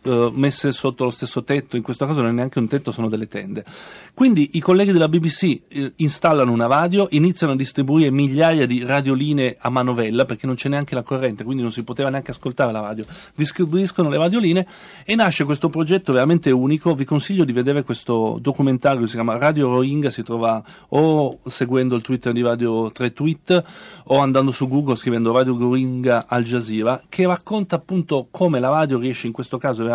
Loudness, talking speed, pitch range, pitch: -19 LUFS, 190 wpm, 125-155 Hz, 135 Hz